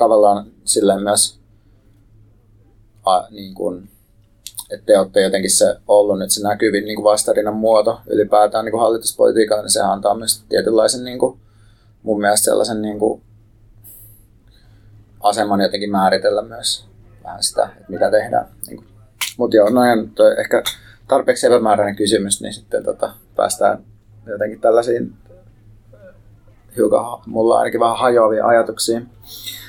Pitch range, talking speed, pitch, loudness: 105-110 Hz, 130 wpm, 110 Hz, -16 LUFS